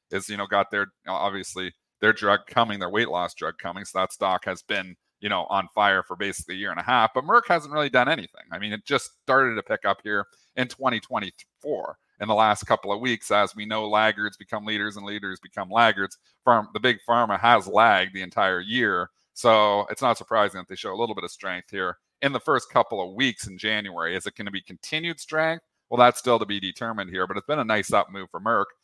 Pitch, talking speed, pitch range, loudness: 110 Hz, 240 wpm, 100-125 Hz, -24 LUFS